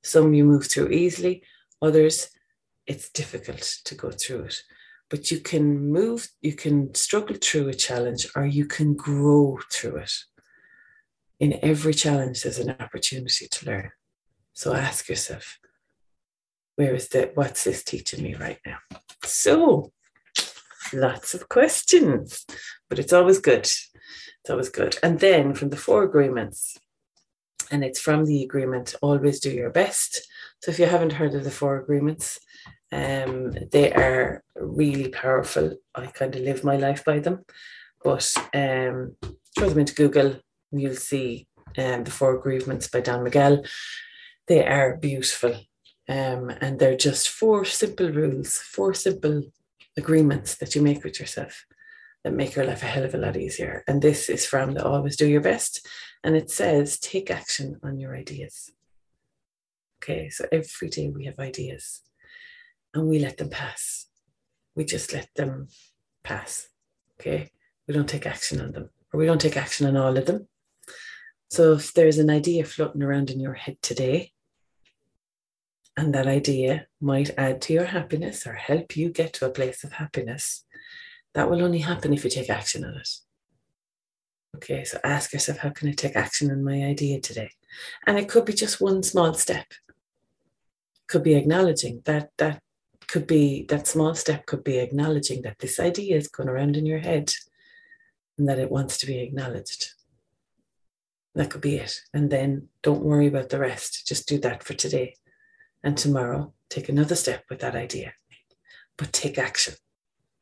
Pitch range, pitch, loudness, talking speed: 135-165 Hz, 145 Hz, -24 LUFS, 165 wpm